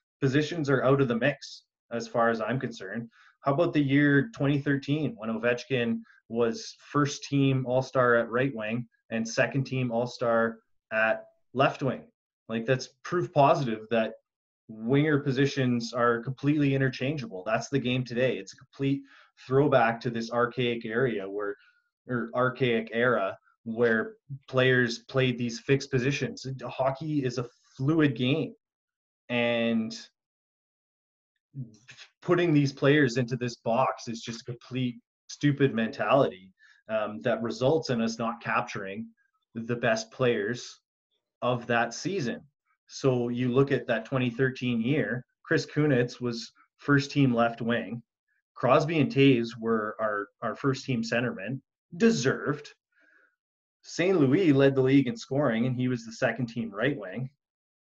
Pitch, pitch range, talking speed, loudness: 125 Hz, 115-140 Hz, 140 wpm, -27 LUFS